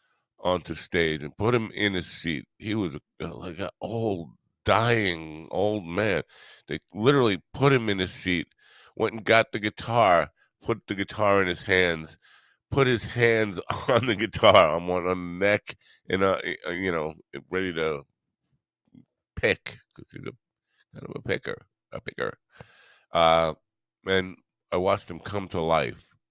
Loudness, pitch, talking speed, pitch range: -25 LUFS, 95 Hz, 155 wpm, 85-110 Hz